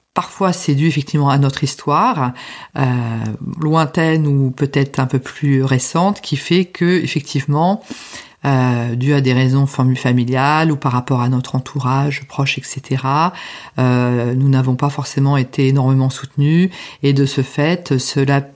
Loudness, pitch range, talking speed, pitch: -16 LUFS, 130-155 Hz, 150 wpm, 140 Hz